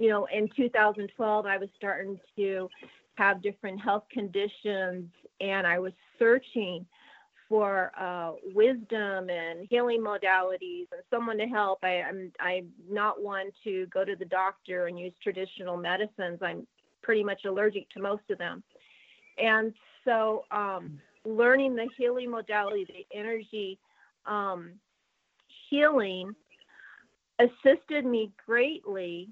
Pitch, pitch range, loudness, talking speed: 205 Hz, 185-225 Hz, -29 LUFS, 125 wpm